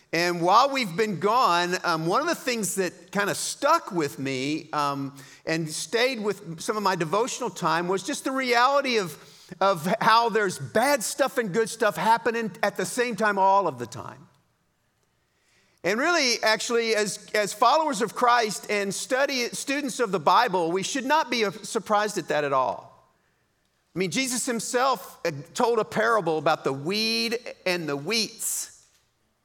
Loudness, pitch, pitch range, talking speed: -24 LUFS, 210 Hz, 180-240 Hz, 170 wpm